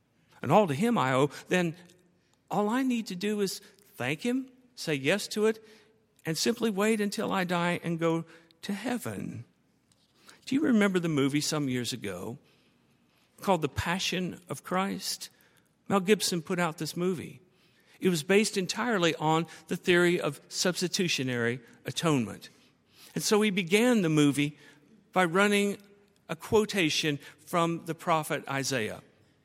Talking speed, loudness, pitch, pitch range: 145 wpm, -29 LUFS, 180 Hz, 160-205 Hz